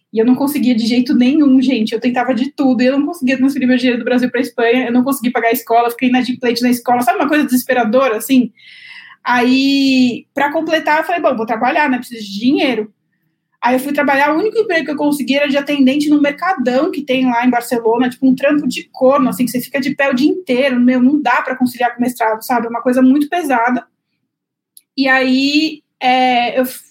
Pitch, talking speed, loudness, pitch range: 255 Hz, 230 wpm, -14 LUFS, 245-285 Hz